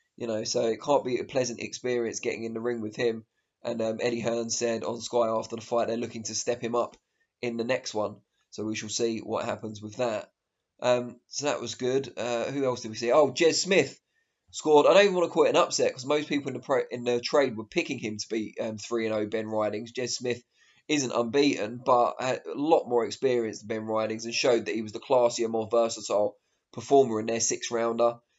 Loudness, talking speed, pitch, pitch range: -27 LUFS, 235 wpm, 120 Hz, 110-125 Hz